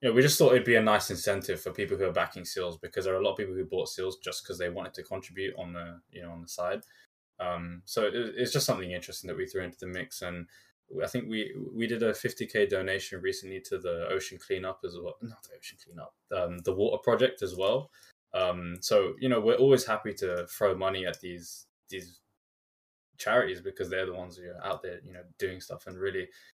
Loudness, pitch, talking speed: -30 LUFS, 125 Hz, 240 wpm